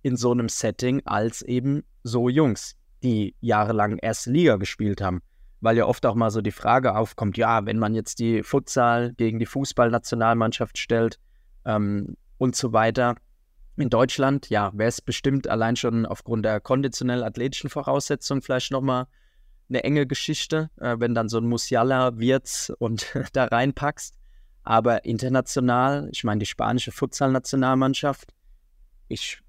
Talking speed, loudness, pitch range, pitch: 150 wpm, -24 LUFS, 110-135 Hz, 120 Hz